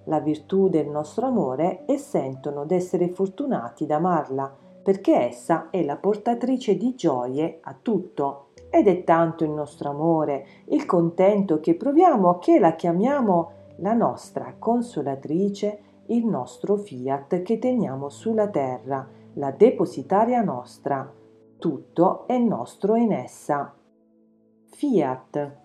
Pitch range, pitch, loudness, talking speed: 140-210 Hz, 170 Hz, -23 LUFS, 120 wpm